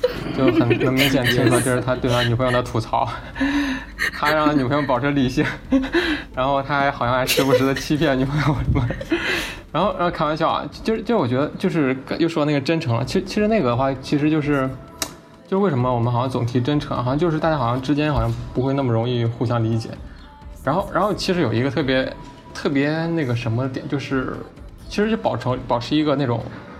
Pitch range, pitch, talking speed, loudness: 125-155 Hz, 135 Hz, 330 characters per minute, -21 LUFS